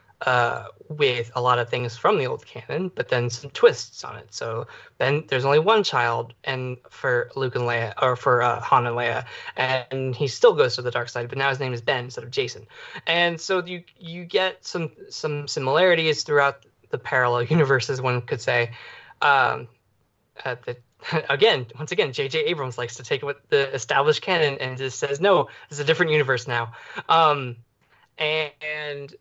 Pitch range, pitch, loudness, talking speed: 125-155 Hz, 135 Hz, -23 LUFS, 190 wpm